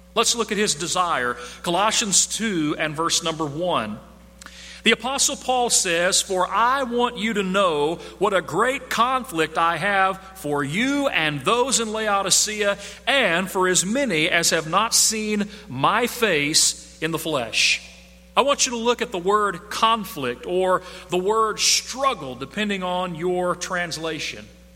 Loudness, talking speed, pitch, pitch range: -21 LUFS, 155 wpm, 190 Hz, 165-220 Hz